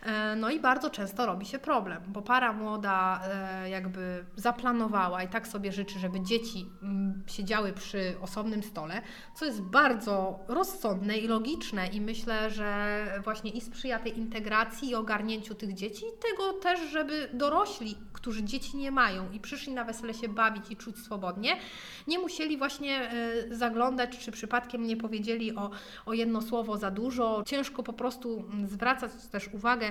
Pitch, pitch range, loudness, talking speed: 225 Hz, 205-245 Hz, -32 LUFS, 155 wpm